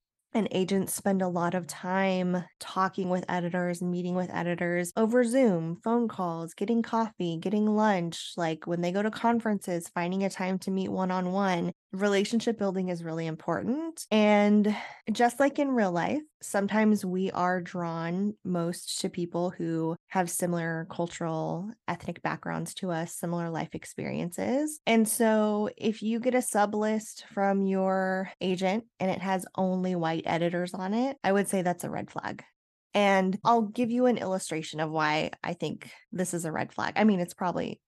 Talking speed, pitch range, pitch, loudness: 175 wpm, 175-215 Hz, 190 Hz, -29 LUFS